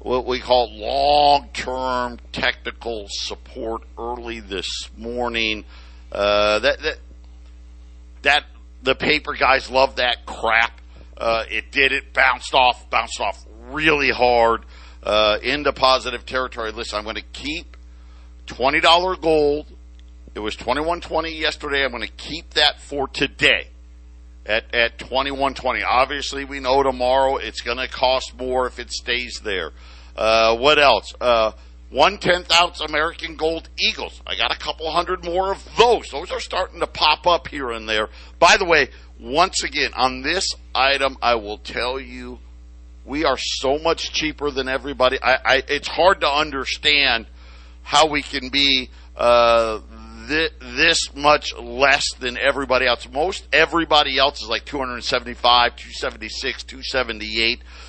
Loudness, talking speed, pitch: -19 LUFS, 145 wpm, 125 Hz